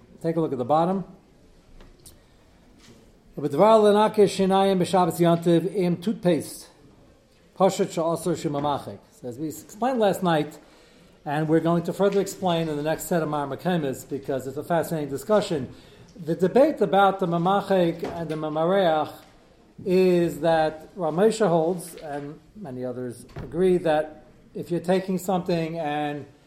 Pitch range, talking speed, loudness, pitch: 155-190 Hz, 115 wpm, -24 LUFS, 170 Hz